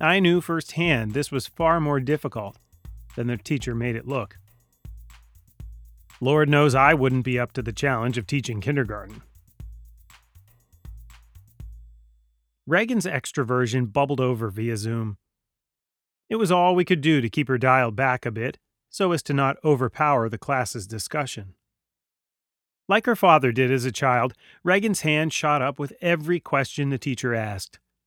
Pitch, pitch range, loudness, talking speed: 125 Hz, 105-145 Hz, -23 LUFS, 150 wpm